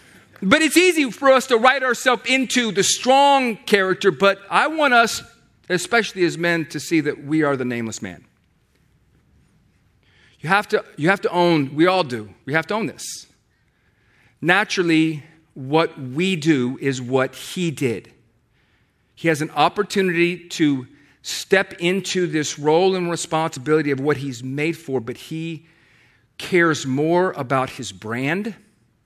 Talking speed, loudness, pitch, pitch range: 150 wpm, -19 LUFS, 160 Hz, 135-195 Hz